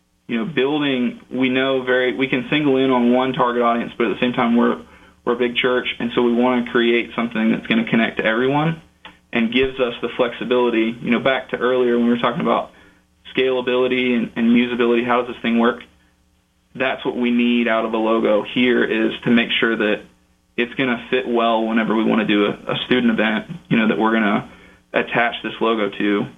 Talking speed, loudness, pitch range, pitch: 225 wpm, -19 LUFS, 110-125 Hz, 120 Hz